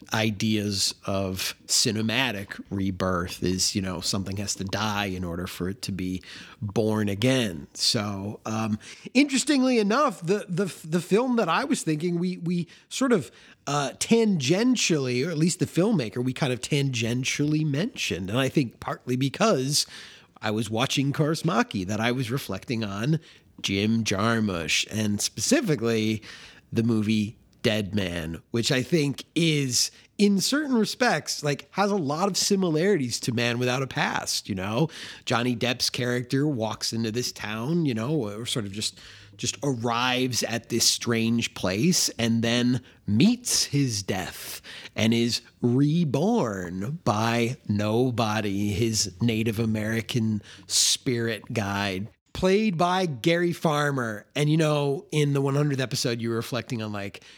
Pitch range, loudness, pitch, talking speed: 105-150 Hz, -25 LUFS, 120 Hz, 145 wpm